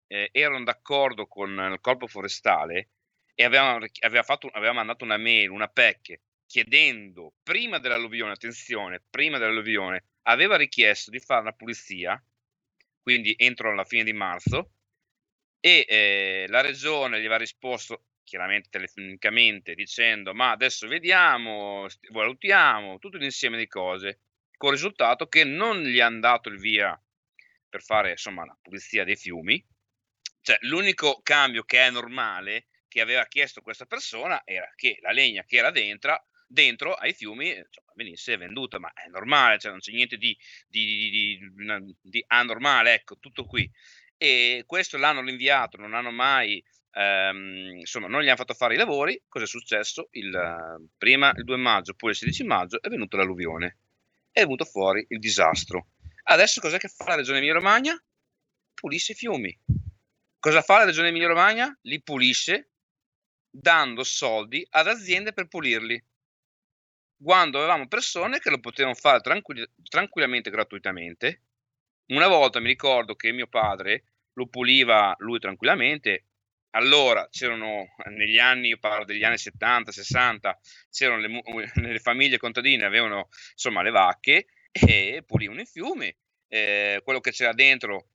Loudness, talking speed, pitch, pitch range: -22 LUFS, 150 wpm, 115 Hz, 100-130 Hz